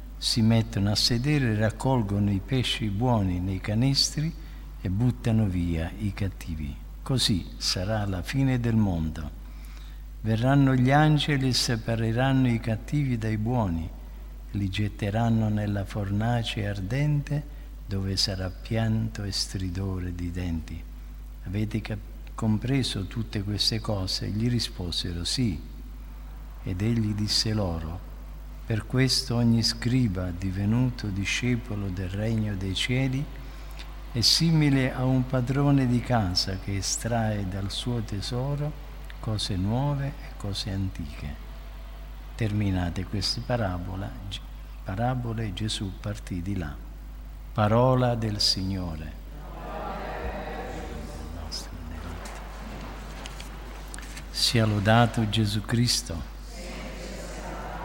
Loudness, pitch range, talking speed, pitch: -27 LUFS, 95-120 Hz, 100 wpm, 110 Hz